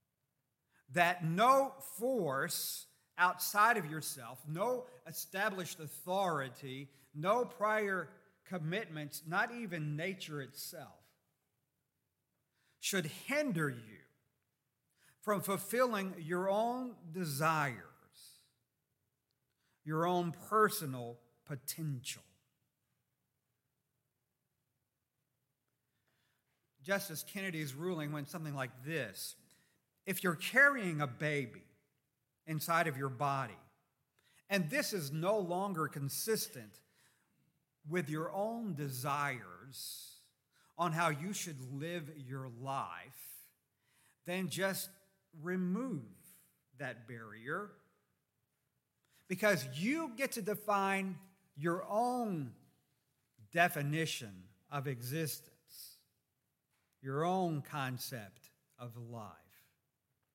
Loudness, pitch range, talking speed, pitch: -37 LUFS, 135-185 Hz, 80 wpm, 155 Hz